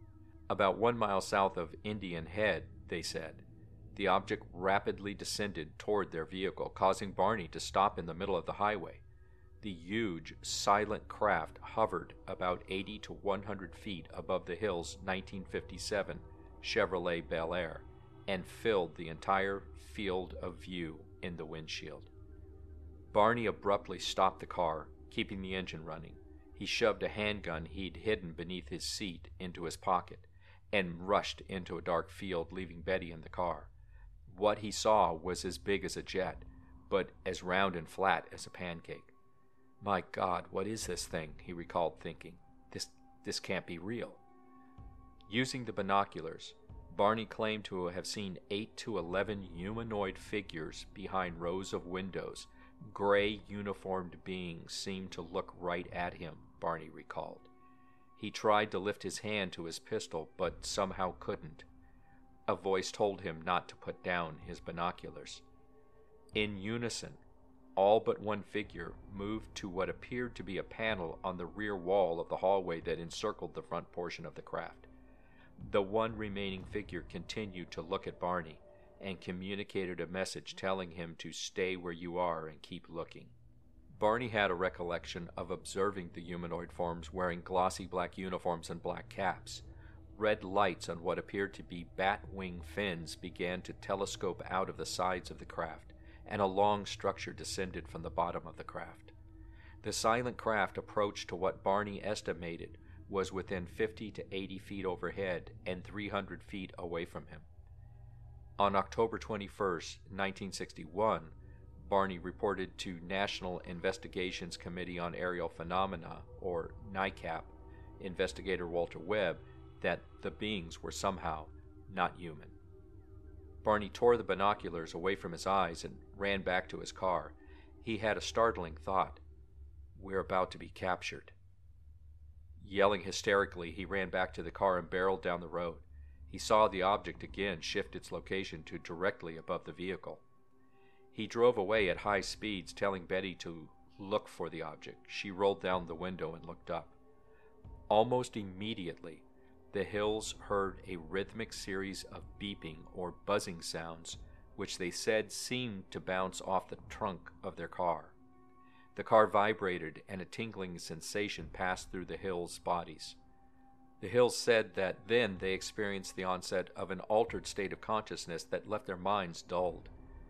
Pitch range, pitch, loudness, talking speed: 85-100 Hz, 95 Hz, -37 LUFS, 155 wpm